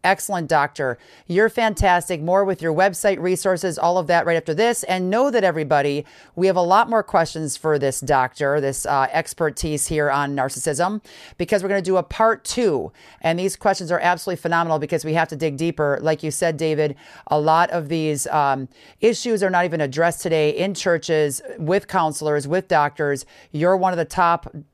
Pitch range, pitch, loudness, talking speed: 150-185 Hz, 165 Hz, -20 LUFS, 195 wpm